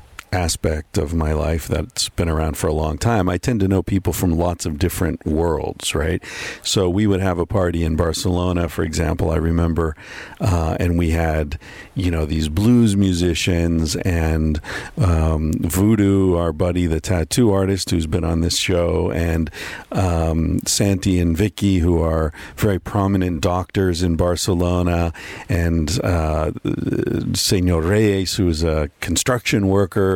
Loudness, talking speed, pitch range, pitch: -19 LUFS, 155 wpm, 80-95 Hz, 90 Hz